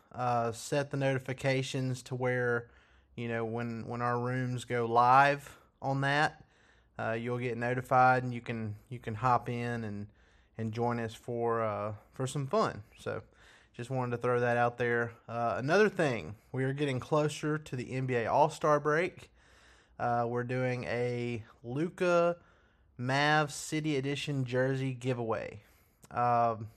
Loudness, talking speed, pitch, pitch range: -32 LUFS, 150 wpm, 125 Hz, 120-135 Hz